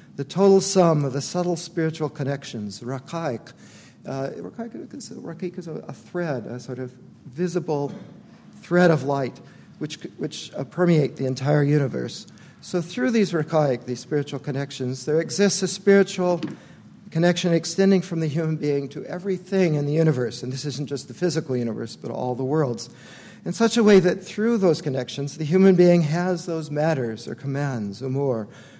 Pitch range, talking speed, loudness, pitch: 135-180 Hz, 165 wpm, -23 LUFS, 160 Hz